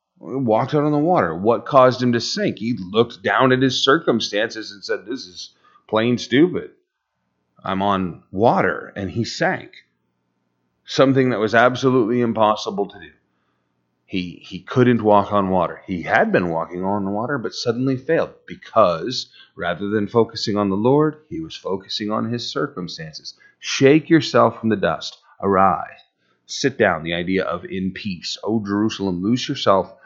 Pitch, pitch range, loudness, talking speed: 105 Hz, 90-125 Hz, -19 LUFS, 160 wpm